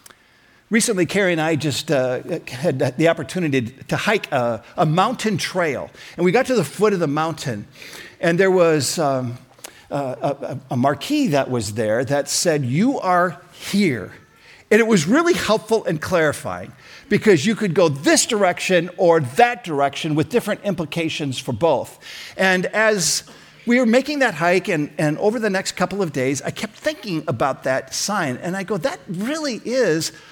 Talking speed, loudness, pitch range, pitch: 175 wpm, -20 LUFS, 150-215 Hz, 175 Hz